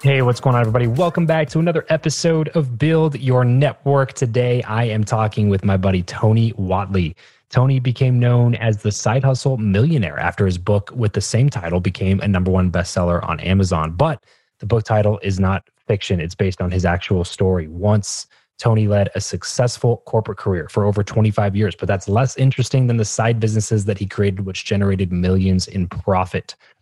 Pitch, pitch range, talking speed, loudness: 105 Hz, 95-125 Hz, 190 wpm, -18 LUFS